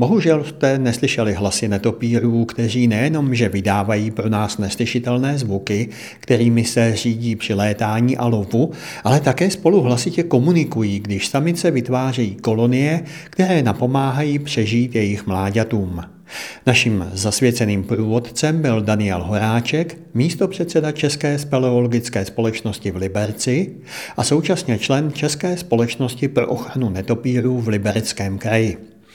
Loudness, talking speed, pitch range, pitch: -19 LUFS, 115 wpm, 110-135 Hz, 120 Hz